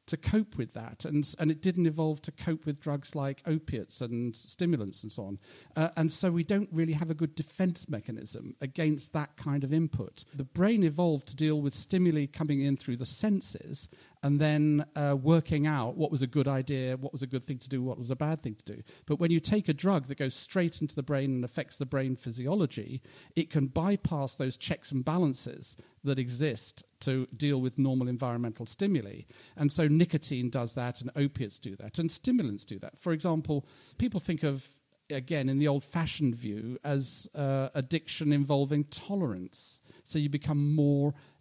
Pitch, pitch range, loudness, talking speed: 145 Hz, 130-160 Hz, -31 LUFS, 200 wpm